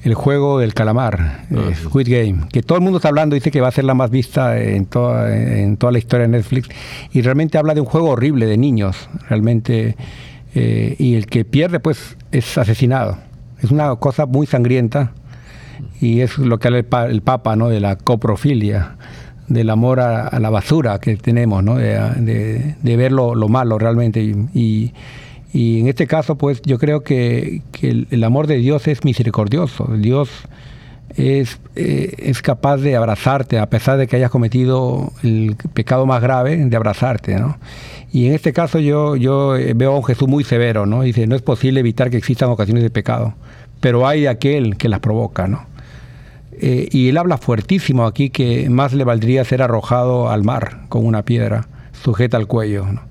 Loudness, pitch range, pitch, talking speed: -16 LUFS, 115-135 Hz, 125 Hz, 195 wpm